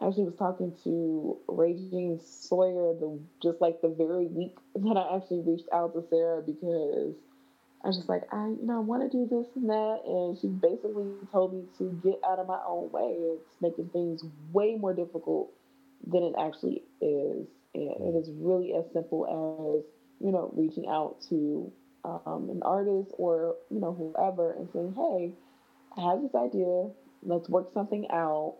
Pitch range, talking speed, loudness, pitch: 165-200 Hz, 180 wpm, -31 LUFS, 180 Hz